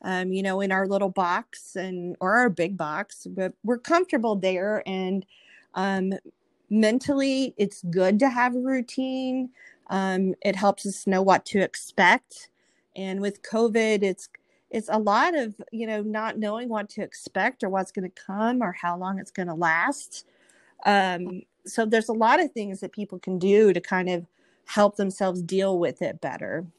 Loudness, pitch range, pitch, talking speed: -25 LUFS, 185-225 Hz, 200 Hz, 180 wpm